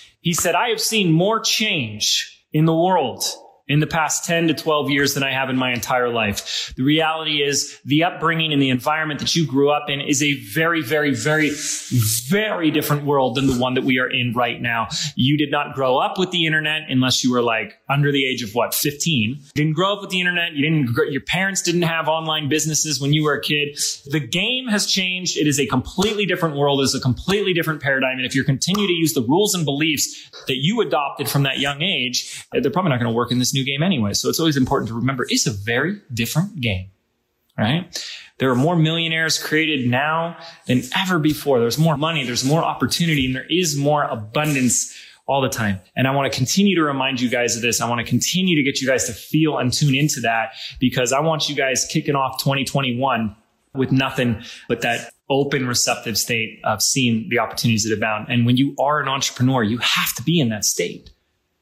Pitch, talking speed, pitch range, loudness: 140 Hz, 220 wpm, 125-160 Hz, -19 LUFS